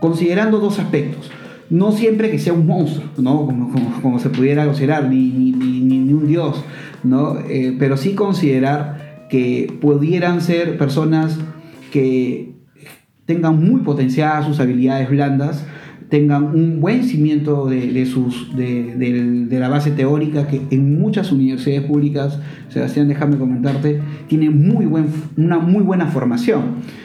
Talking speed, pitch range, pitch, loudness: 145 wpm, 130-160 Hz, 145 Hz, -16 LUFS